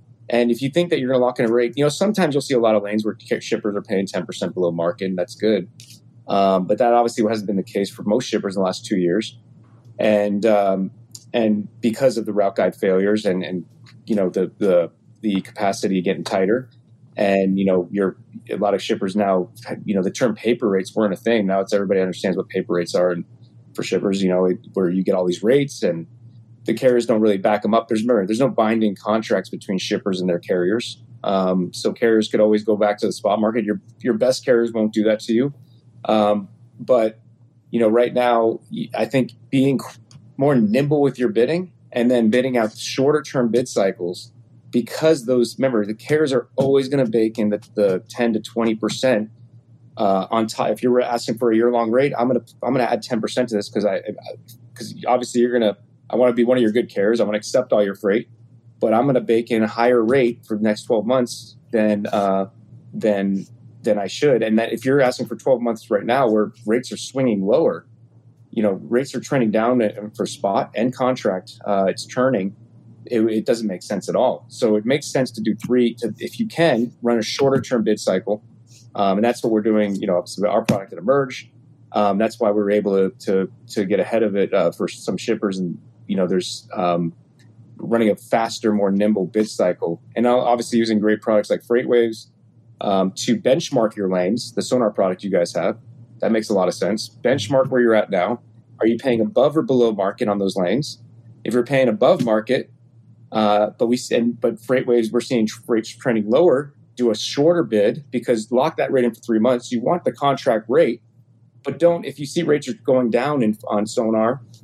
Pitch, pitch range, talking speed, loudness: 115 Hz, 105-125 Hz, 220 wpm, -20 LUFS